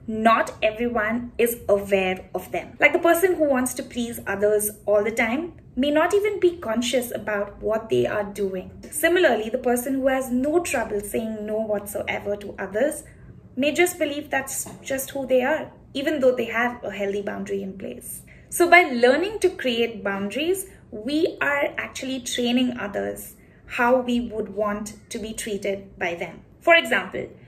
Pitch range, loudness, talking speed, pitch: 210-285 Hz, -23 LUFS, 170 wpm, 240 Hz